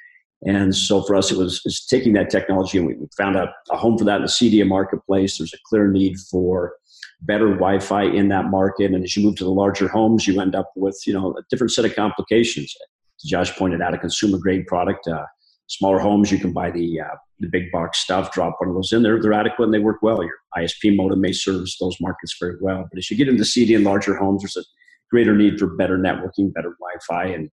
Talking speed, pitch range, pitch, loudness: 240 wpm, 90-105 Hz, 95 Hz, -19 LUFS